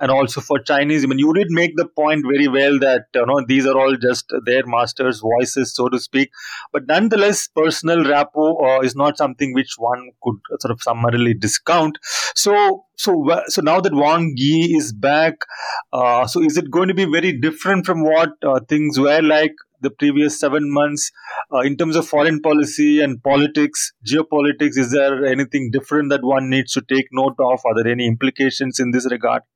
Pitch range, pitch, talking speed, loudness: 130-155 Hz, 140 Hz, 195 wpm, -17 LUFS